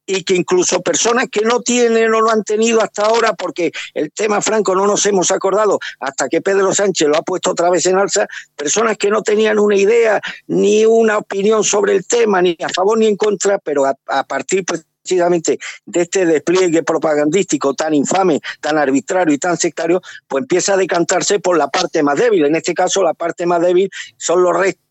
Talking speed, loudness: 200 wpm, -15 LUFS